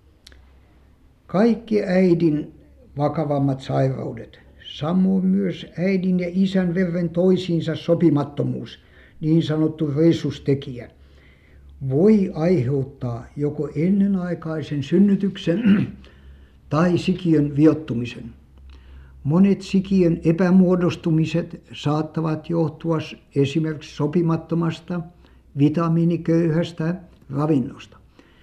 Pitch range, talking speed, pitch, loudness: 135-175 Hz, 70 wpm, 160 Hz, -21 LUFS